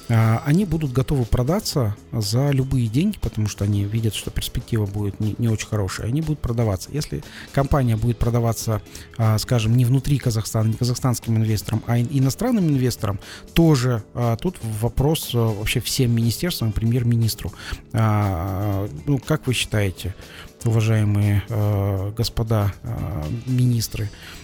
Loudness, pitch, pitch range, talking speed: -22 LUFS, 115 Hz, 105-125 Hz, 120 wpm